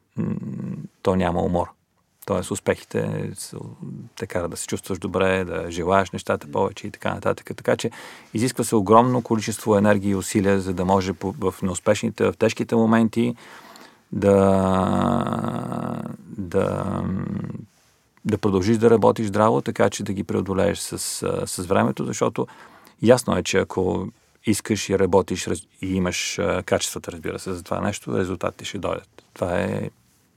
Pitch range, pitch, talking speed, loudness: 95-115 Hz, 100 Hz, 140 wpm, -23 LUFS